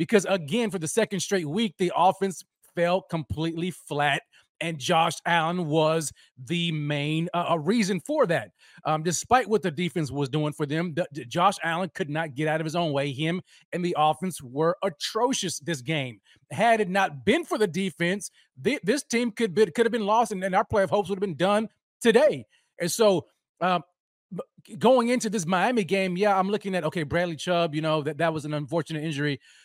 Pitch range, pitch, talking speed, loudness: 160-200 Hz, 175 Hz, 205 wpm, -26 LUFS